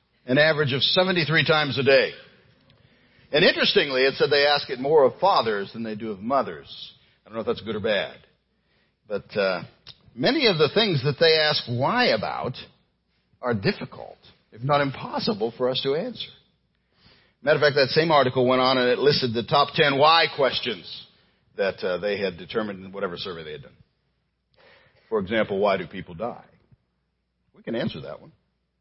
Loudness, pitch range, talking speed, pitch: -22 LUFS, 125-160 Hz, 185 wpm, 145 Hz